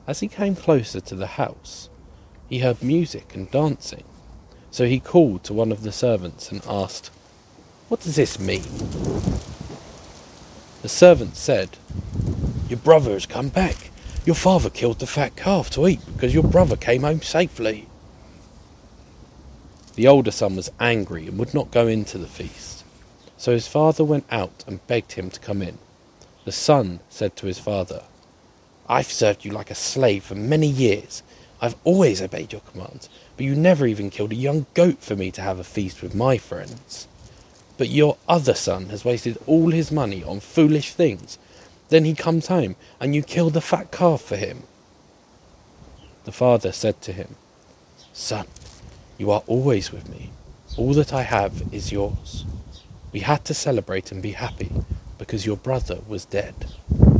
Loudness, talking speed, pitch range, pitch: -21 LUFS, 170 wpm, 95-145 Hz, 115 Hz